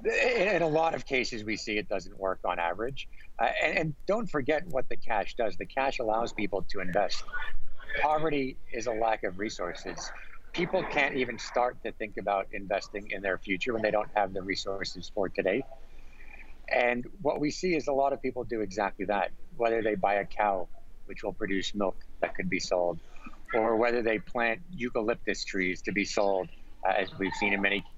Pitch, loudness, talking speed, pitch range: 115 Hz, -30 LUFS, 195 wpm, 100-140 Hz